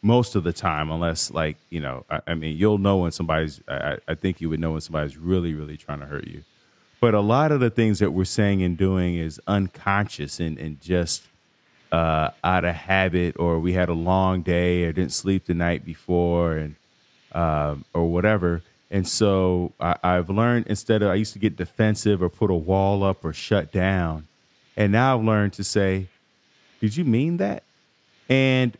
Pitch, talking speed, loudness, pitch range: 90 Hz, 200 wpm, -23 LUFS, 80-105 Hz